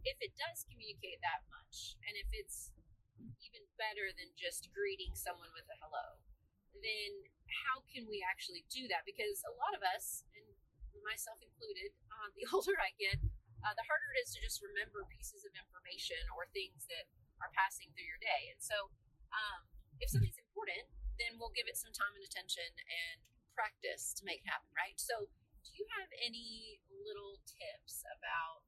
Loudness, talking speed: -43 LUFS, 180 wpm